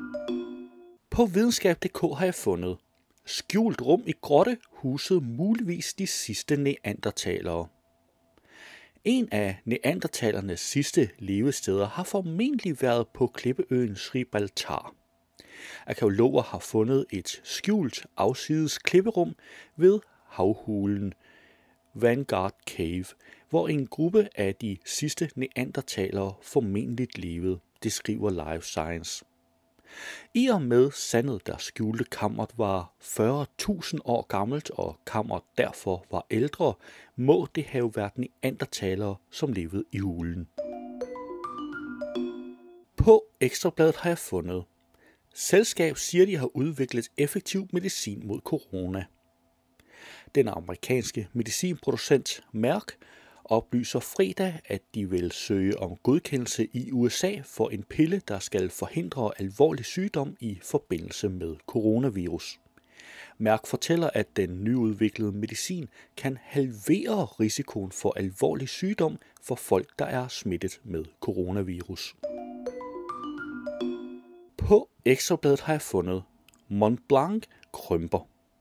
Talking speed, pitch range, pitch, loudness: 110 wpm, 100-160 Hz, 120 Hz, -28 LUFS